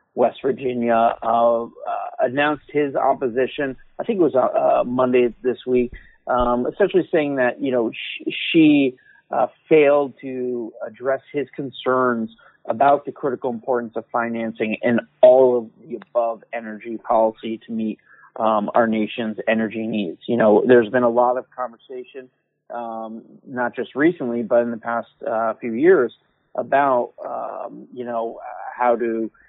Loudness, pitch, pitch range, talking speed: -20 LUFS, 125 Hz, 115-135 Hz, 155 wpm